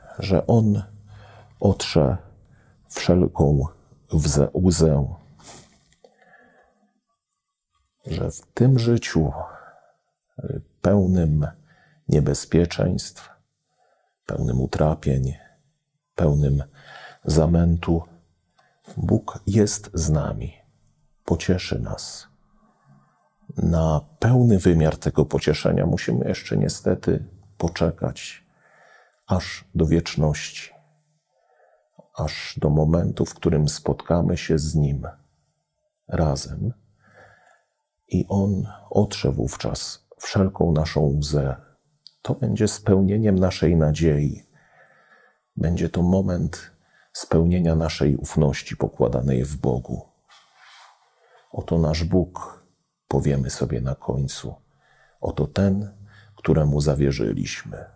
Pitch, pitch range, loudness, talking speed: 85 Hz, 75-105 Hz, -22 LUFS, 80 wpm